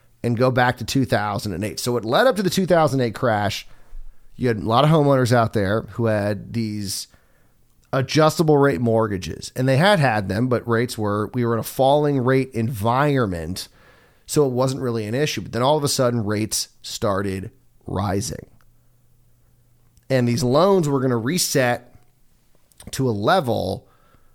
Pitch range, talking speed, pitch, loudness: 110-130 Hz, 165 wpm, 120 Hz, -20 LUFS